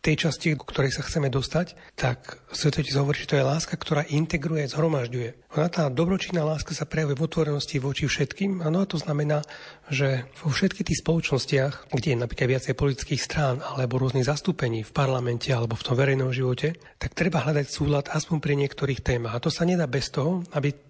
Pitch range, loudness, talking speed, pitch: 135-160 Hz, -26 LUFS, 195 wpm, 145 Hz